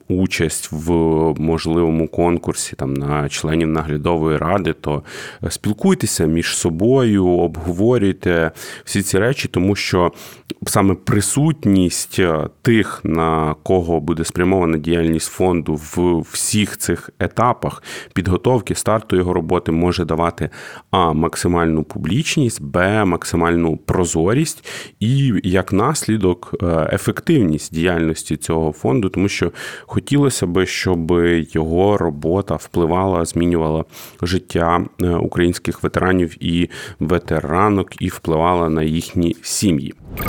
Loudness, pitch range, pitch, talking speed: -18 LUFS, 80-95 Hz, 85 Hz, 105 wpm